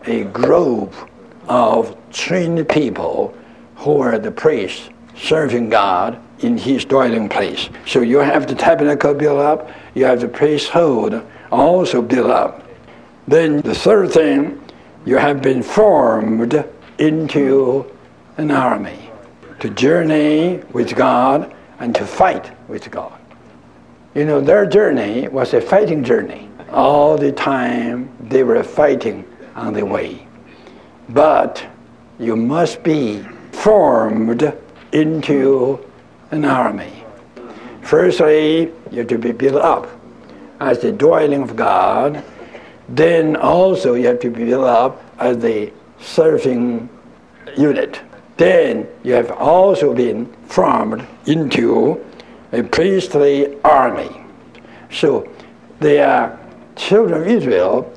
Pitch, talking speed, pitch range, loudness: 145 Hz, 120 wpm, 125-160 Hz, -15 LUFS